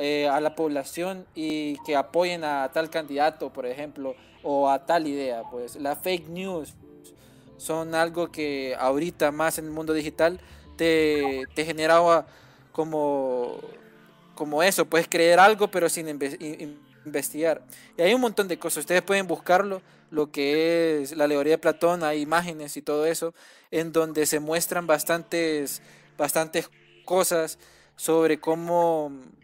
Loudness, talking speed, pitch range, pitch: -25 LUFS, 145 wpm, 145-165 Hz, 155 Hz